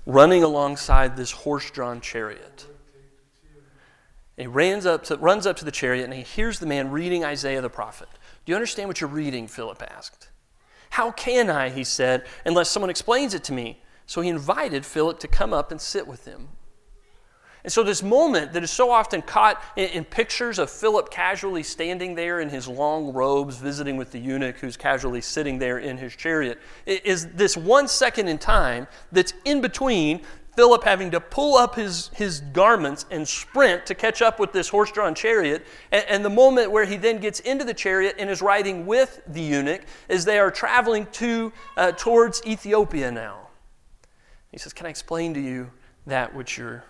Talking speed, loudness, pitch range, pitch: 190 wpm, -22 LUFS, 140-215 Hz, 170 Hz